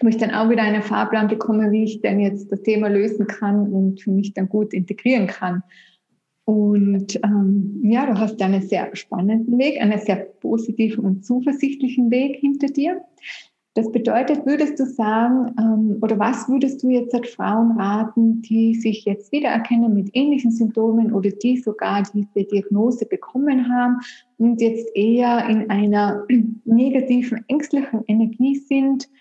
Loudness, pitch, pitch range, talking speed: -19 LUFS, 225 Hz, 205-245 Hz, 160 wpm